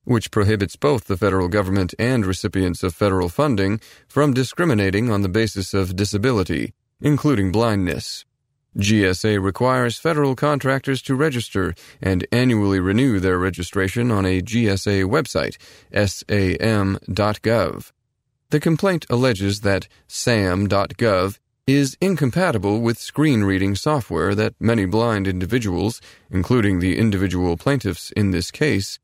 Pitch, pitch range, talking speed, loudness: 105 Hz, 95-125 Hz, 120 wpm, -20 LUFS